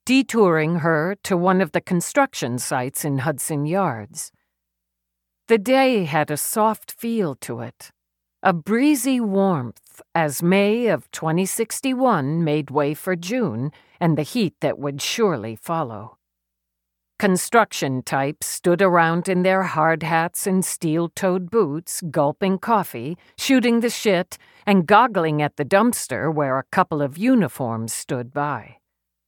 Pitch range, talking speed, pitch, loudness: 140-200 Hz, 135 wpm, 165 Hz, -21 LUFS